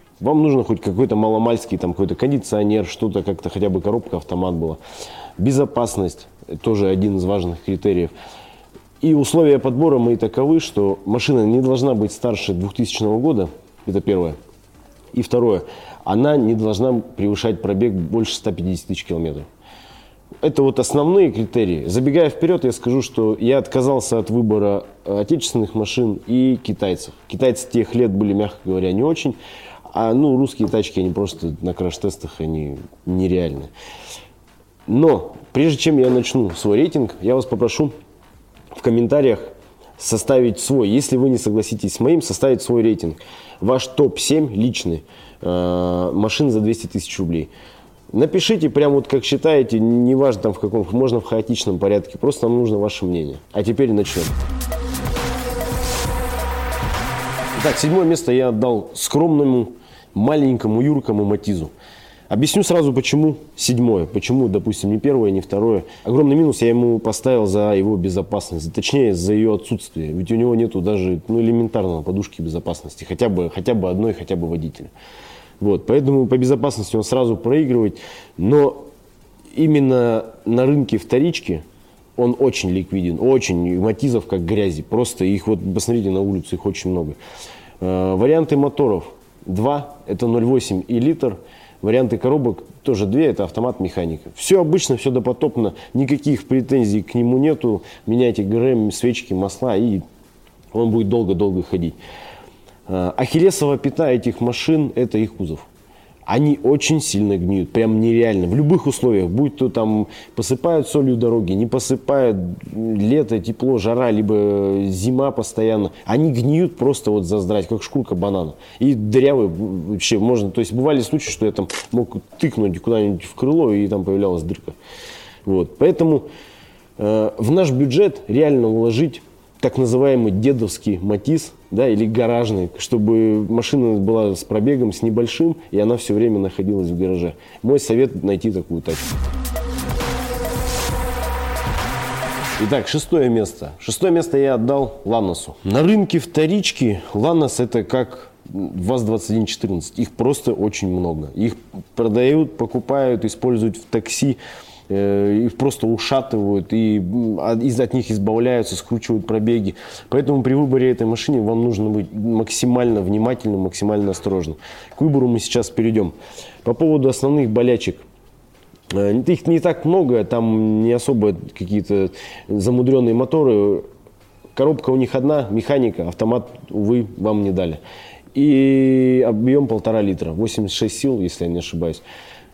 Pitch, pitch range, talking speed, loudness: 115 Hz, 100-130 Hz, 140 wpm, -18 LUFS